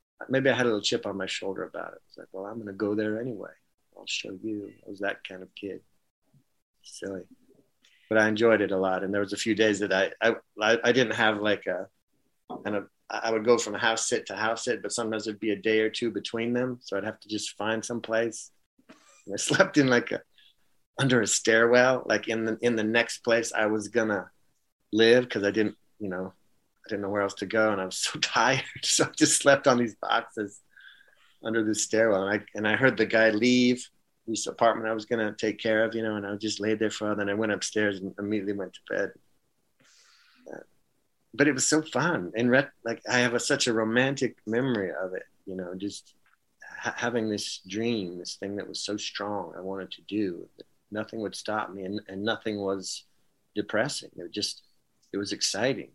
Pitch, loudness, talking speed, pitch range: 110 Hz, -27 LUFS, 225 wpm, 100-115 Hz